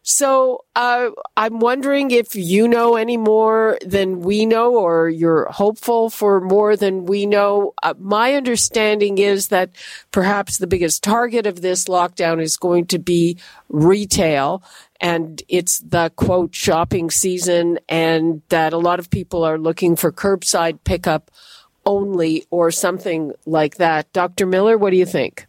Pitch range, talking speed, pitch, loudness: 170-210 Hz, 155 wpm, 185 Hz, -17 LUFS